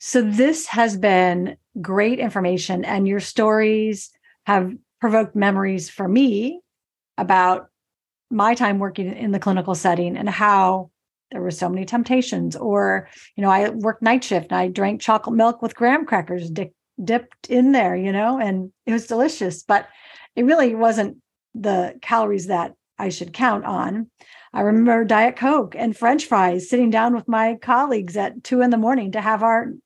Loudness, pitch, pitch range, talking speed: -20 LUFS, 215 Hz, 190-235 Hz, 170 wpm